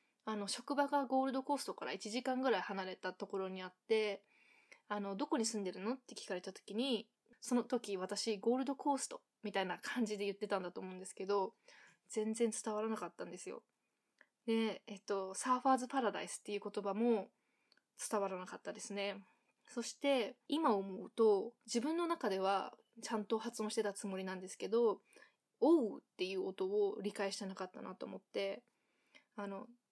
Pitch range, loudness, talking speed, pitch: 200-255 Hz, -39 LUFS, 360 characters per minute, 220 Hz